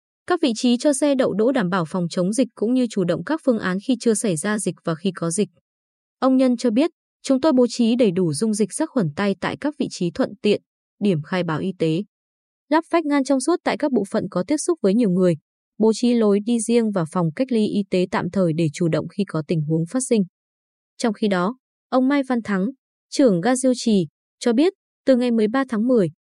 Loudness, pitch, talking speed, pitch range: -21 LUFS, 220 Hz, 250 wpm, 185-260 Hz